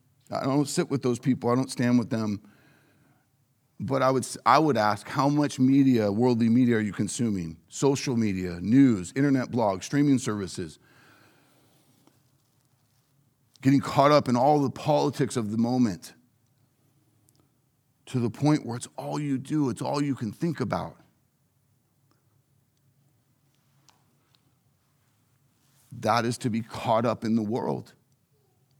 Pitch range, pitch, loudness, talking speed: 120-140 Hz, 130 Hz, -25 LUFS, 135 wpm